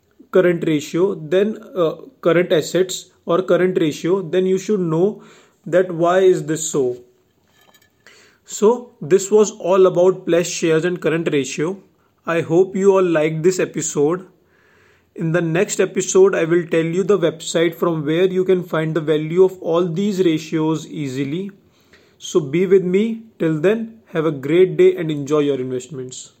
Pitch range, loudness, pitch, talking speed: 160-190 Hz, -18 LUFS, 175 Hz, 160 wpm